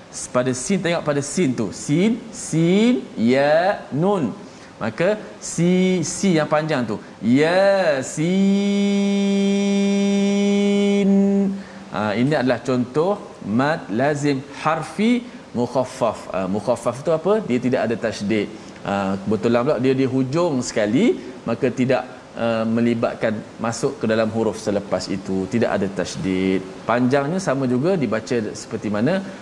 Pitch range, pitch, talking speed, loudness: 120-195 Hz, 140 Hz, 120 wpm, -20 LUFS